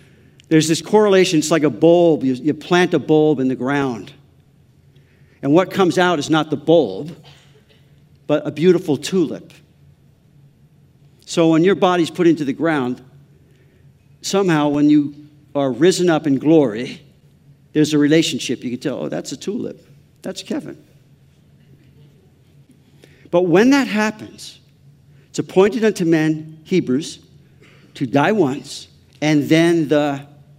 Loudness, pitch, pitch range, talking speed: -17 LUFS, 150 Hz, 140-165 Hz, 135 wpm